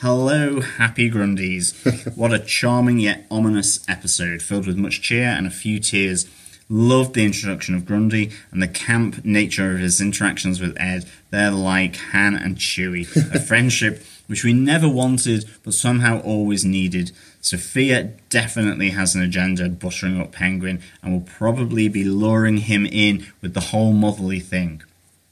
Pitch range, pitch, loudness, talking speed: 90-110 Hz, 100 Hz, -19 LUFS, 155 wpm